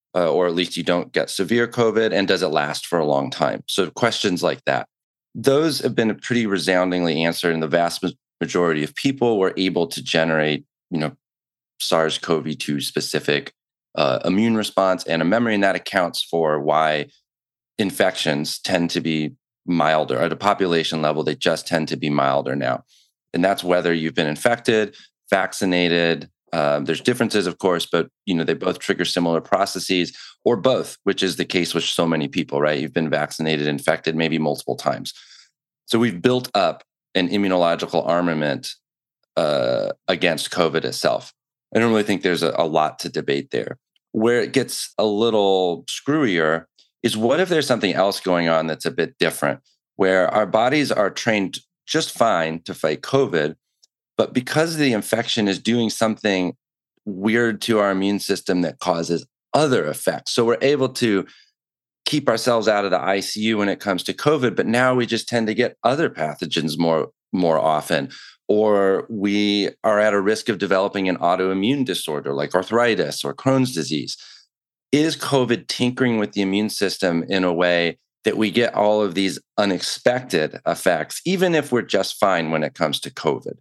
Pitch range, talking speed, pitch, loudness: 85-115 Hz, 175 wpm, 95 Hz, -21 LUFS